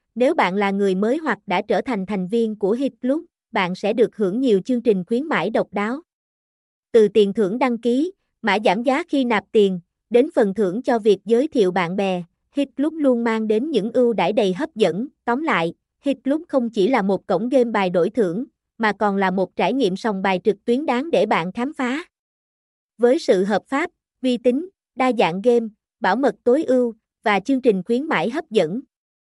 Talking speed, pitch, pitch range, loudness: 205 wpm, 230 Hz, 200-255 Hz, -20 LUFS